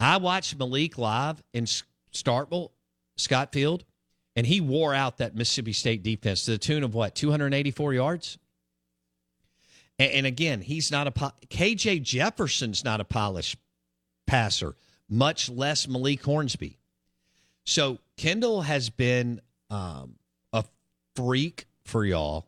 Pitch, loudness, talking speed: 125 Hz, -27 LUFS, 125 wpm